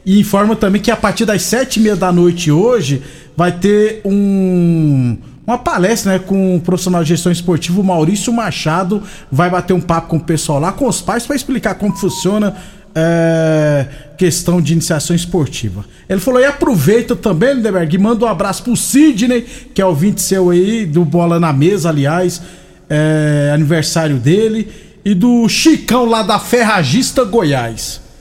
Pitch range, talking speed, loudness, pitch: 165-215 Hz, 175 wpm, -13 LUFS, 185 Hz